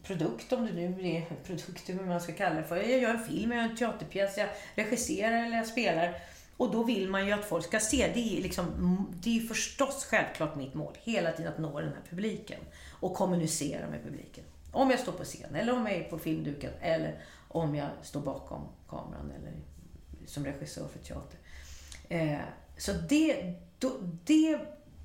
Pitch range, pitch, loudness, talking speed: 155-230 Hz, 180 Hz, -32 LUFS, 190 wpm